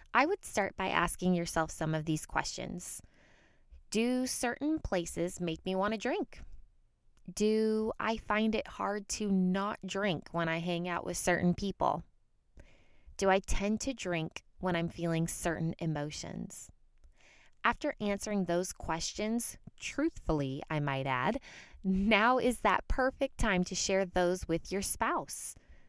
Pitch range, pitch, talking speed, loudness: 170-215 Hz, 190 Hz, 145 wpm, -33 LUFS